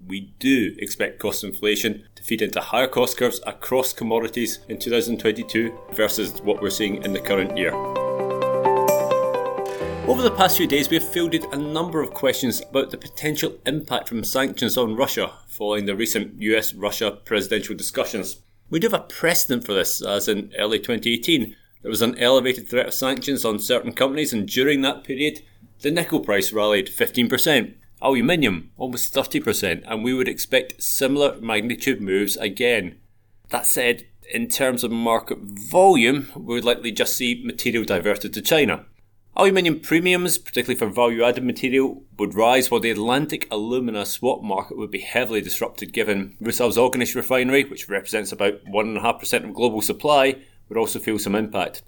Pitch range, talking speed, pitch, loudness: 105-135 Hz, 165 wpm, 120 Hz, -21 LUFS